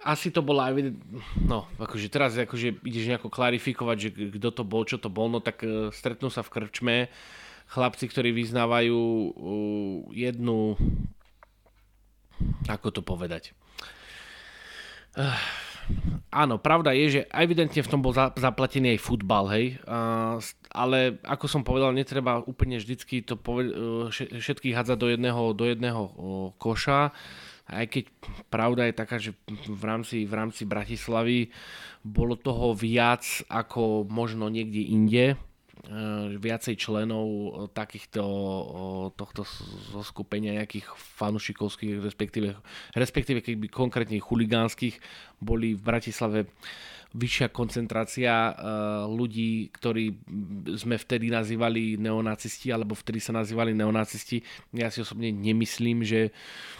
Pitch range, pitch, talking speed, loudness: 110-125 Hz, 115 Hz, 115 wpm, -28 LUFS